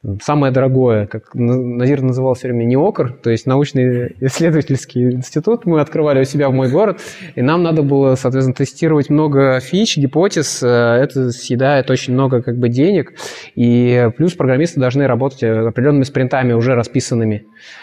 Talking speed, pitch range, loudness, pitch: 150 wpm, 125-145 Hz, -15 LUFS, 130 Hz